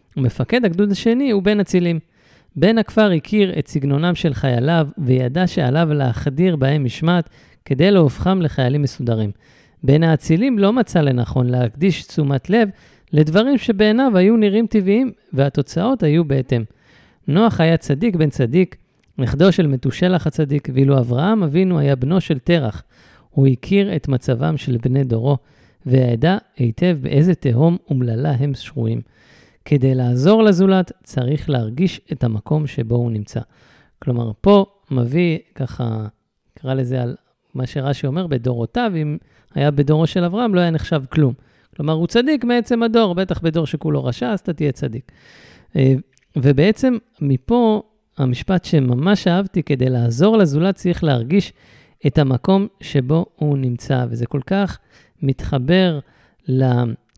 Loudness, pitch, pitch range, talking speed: -18 LUFS, 155 Hz, 130-185 Hz, 135 wpm